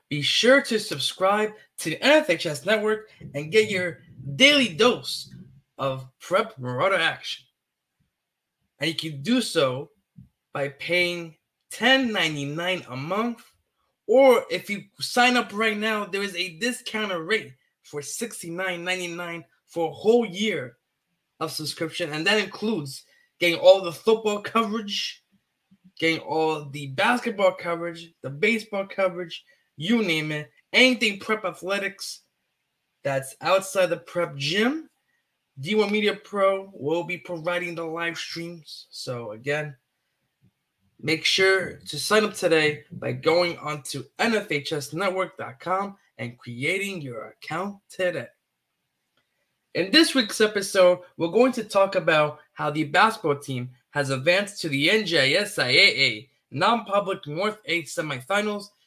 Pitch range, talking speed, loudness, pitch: 150-215 Hz, 125 wpm, -23 LUFS, 180 Hz